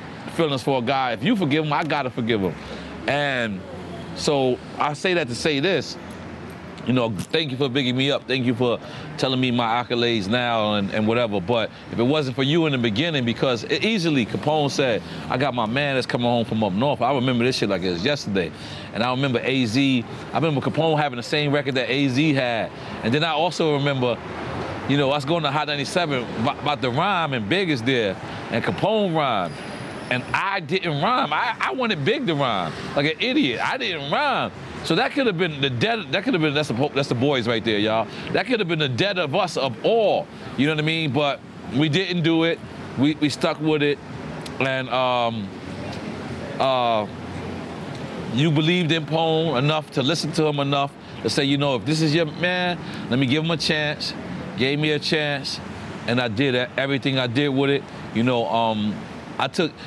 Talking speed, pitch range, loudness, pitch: 210 wpm, 125-155 Hz, -22 LUFS, 140 Hz